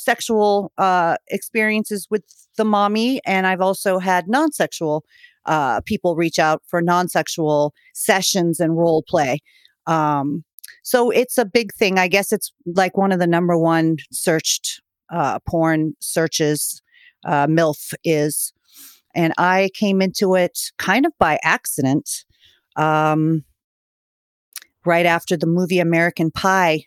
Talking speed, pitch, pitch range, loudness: 130 wpm, 180 Hz, 160-205 Hz, -19 LUFS